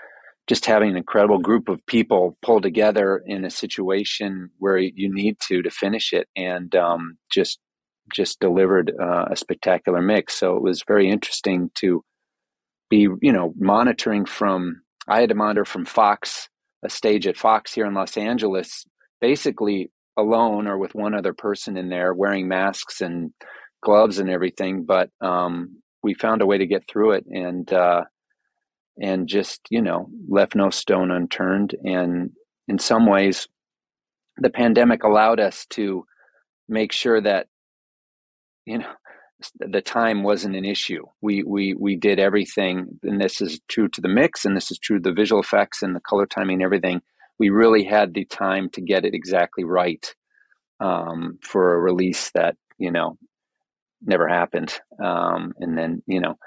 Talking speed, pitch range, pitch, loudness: 165 wpm, 90-105 Hz, 95 Hz, -21 LUFS